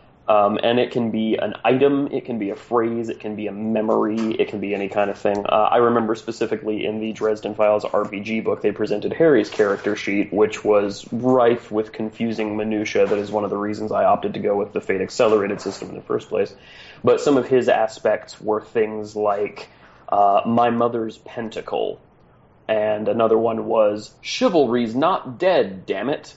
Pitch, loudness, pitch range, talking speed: 110 Hz, -21 LUFS, 105-115 Hz, 195 wpm